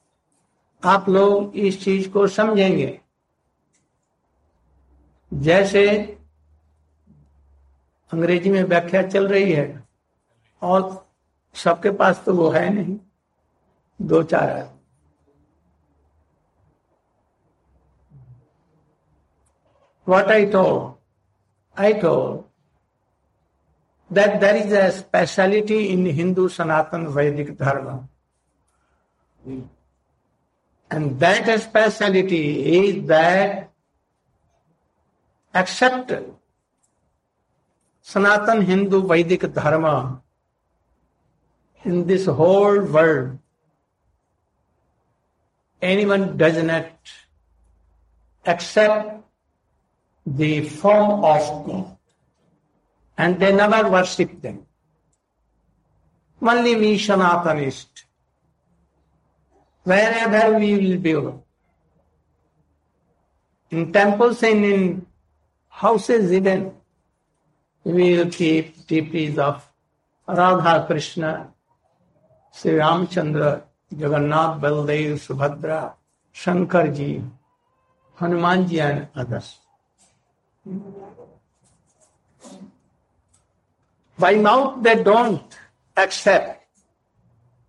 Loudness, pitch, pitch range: -19 LUFS, 165 Hz, 125-195 Hz